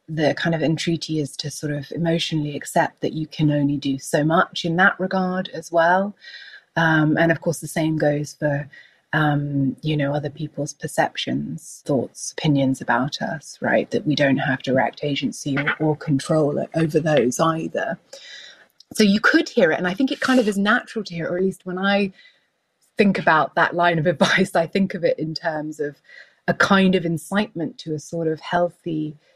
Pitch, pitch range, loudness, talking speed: 160 Hz, 150-185 Hz, -21 LUFS, 195 wpm